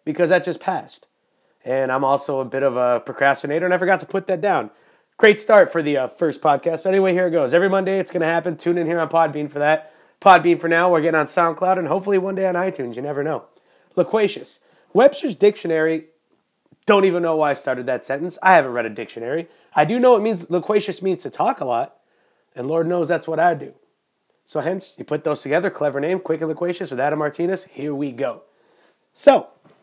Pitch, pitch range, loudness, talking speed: 170 Hz, 150-190 Hz, -19 LUFS, 225 wpm